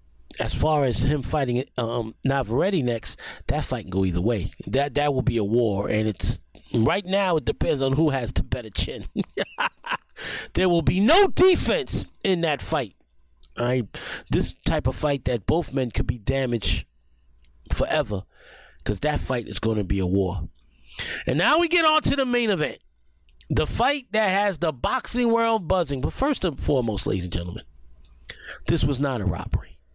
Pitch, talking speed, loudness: 125 Hz, 180 wpm, -24 LUFS